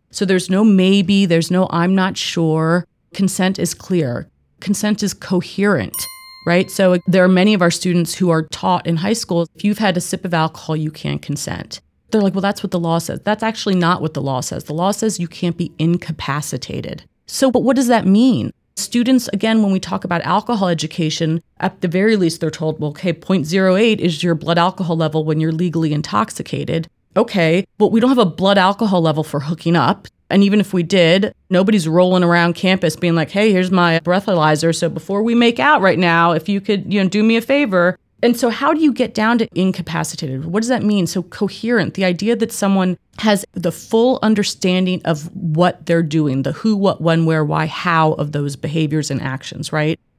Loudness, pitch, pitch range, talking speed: -16 LUFS, 180 Hz, 165-205 Hz, 210 wpm